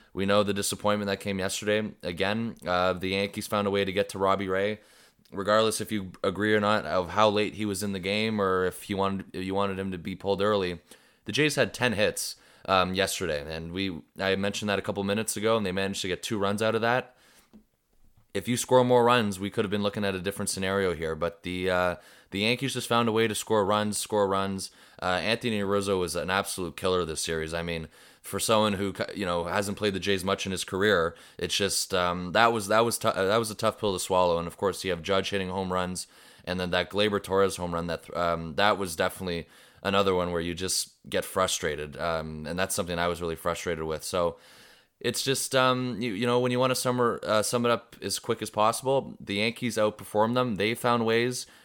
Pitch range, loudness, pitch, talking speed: 90-110 Hz, -27 LUFS, 100 Hz, 235 wpm